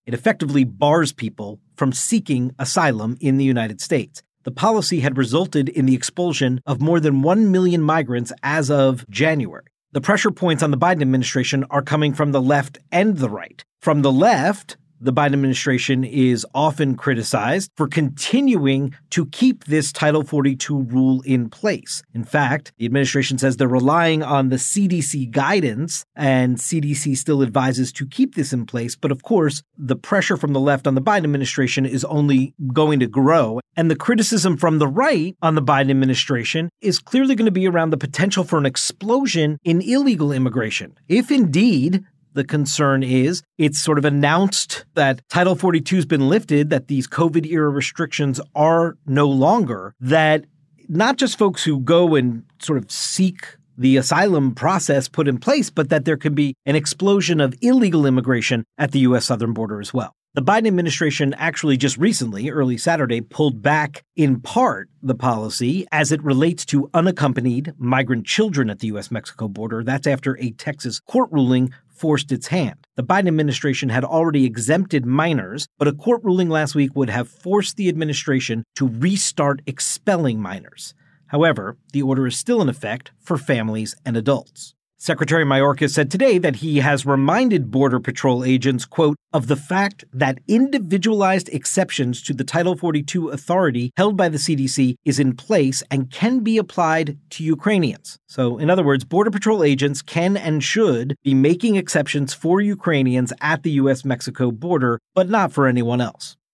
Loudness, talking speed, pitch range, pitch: -19 LUFS, 170 wpm, 130-170 Hz, 145 Hz